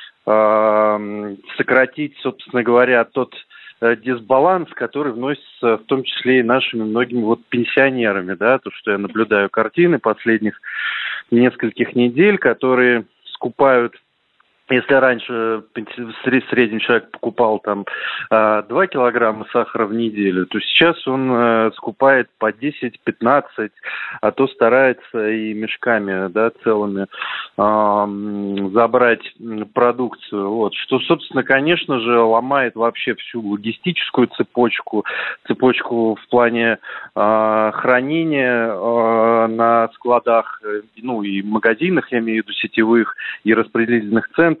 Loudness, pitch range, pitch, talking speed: -17 LUFS, 110-125 Hz, 115 Hz, 115 wpm